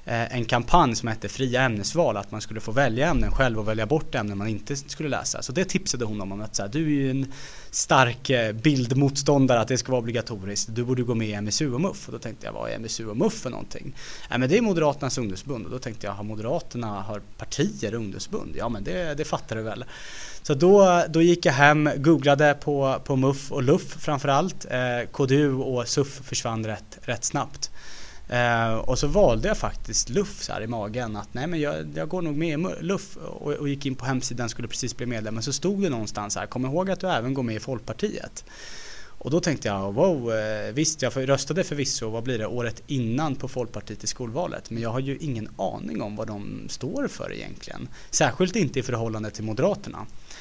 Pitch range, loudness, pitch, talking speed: 110-145 Hz, -25 LUFS, 125 Hz, 215 wpm